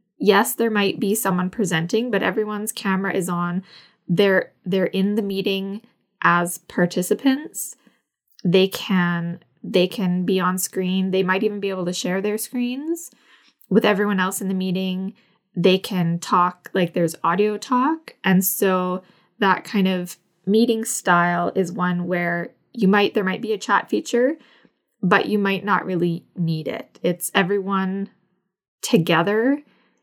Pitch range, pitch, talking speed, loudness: 180-210 Hz, 195 Hz, 150 wpm, -21 LUFS